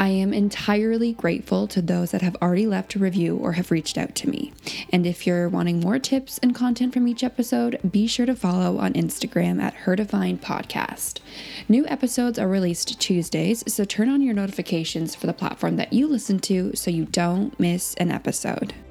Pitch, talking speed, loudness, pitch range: 195 Hz, 190 wpm, -23 LUFS, 175-240 Hz